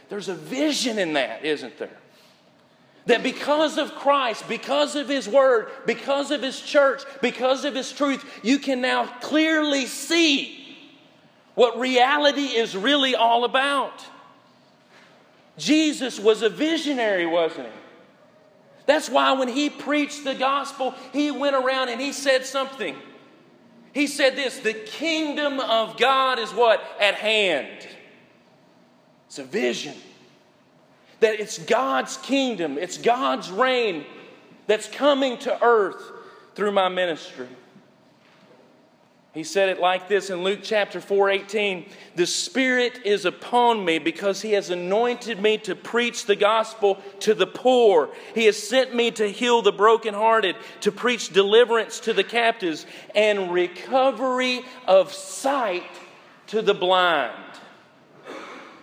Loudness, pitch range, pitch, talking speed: -22 LUFS, 205-275 Hz, 240 Hz, 130 wpm